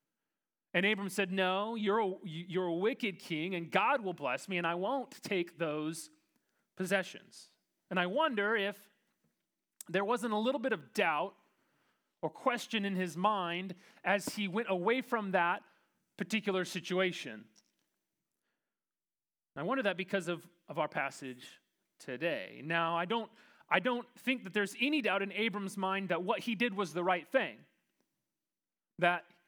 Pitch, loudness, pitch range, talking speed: 195 Hz, -34 LUFS, 180-220 Hz, 155 wpm